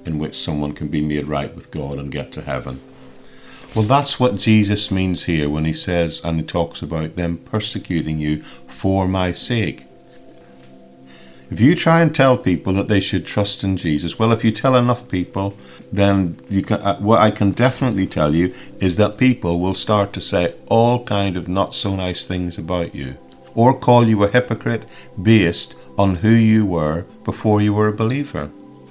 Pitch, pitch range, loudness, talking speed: 95 Hz, 85-110 Hz, -18 LUFS, 190 wpm